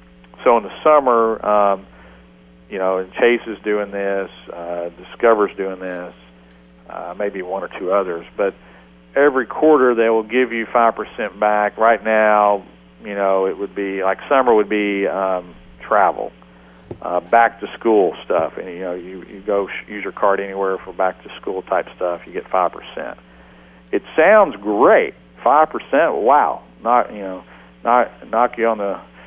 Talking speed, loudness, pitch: 170 wpm, -18 LUFS, 95 Hz